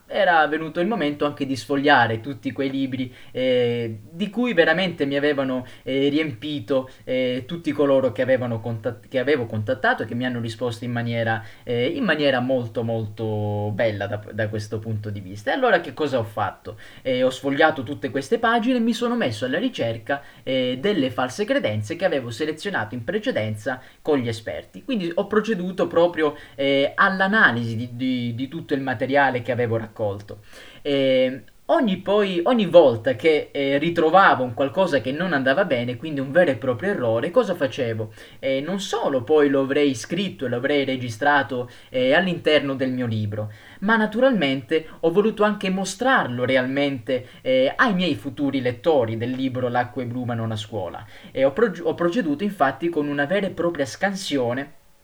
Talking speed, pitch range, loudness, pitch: 170 wpm, 125-175 Hz, -22 LUFS, 140 Hz